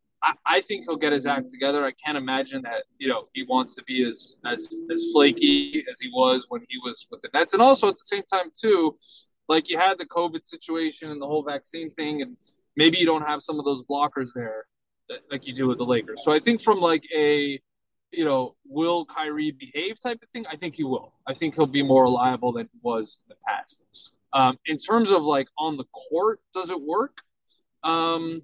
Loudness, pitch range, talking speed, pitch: -24 LUFS, 135-195 Hz, 225 wpm, 155 Hz